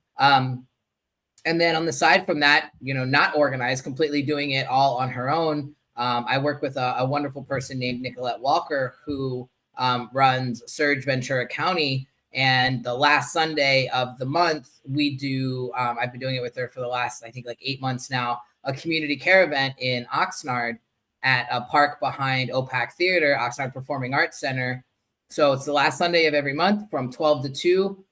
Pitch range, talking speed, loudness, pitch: 125-145 Hz, 190 wpm, -23 LUFS, 135 Hz